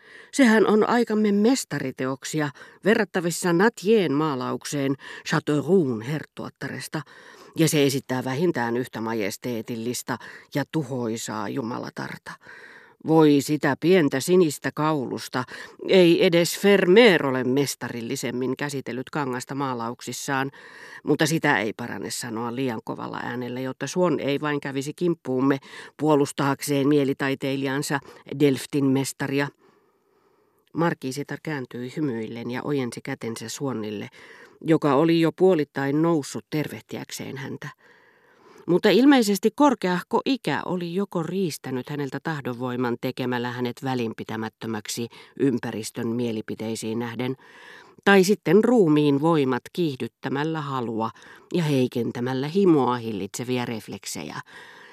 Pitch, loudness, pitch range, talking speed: 140 Hz, -24 LUFS, 125-170 Hz, 100 wpm